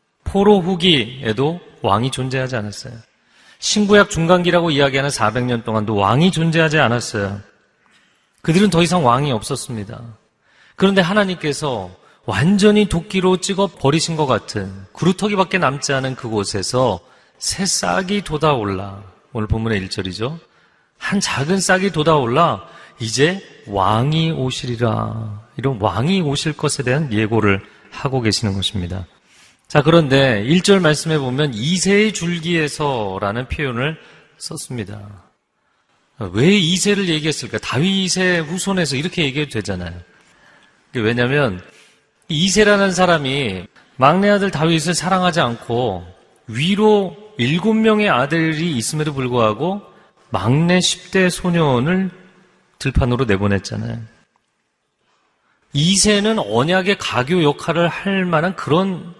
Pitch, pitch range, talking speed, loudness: 145 Hz, 115-180 Hz, 275 characters per minute, -17 LUFS